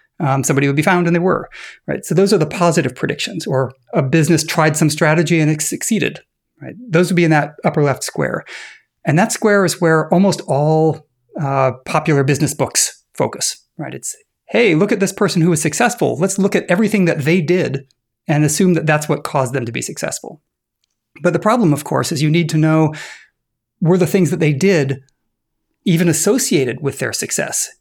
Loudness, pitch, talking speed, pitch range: -16 LUFS, 160 Hz, 200 wpm, 150-180 Hz